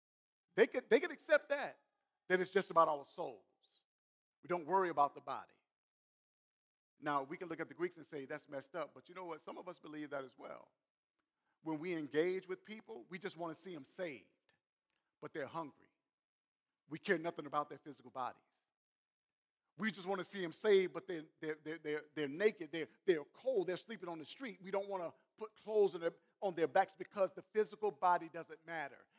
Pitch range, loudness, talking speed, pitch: 155-195 Hz, -40 LUFS, 210 wpm, 175 Hz